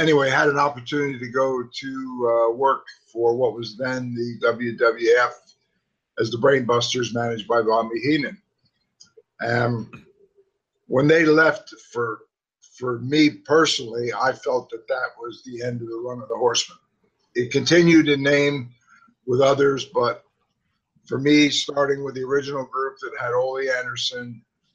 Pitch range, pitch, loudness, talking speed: 120-155 Hz, 135 Hz, -21 LUFS, 150 wpm